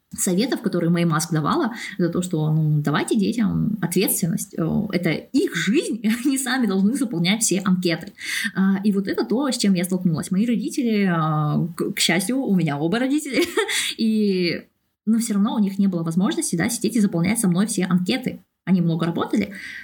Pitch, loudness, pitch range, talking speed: 195 Hz, -21 LUFS, 175-225 Hz, 175 wpm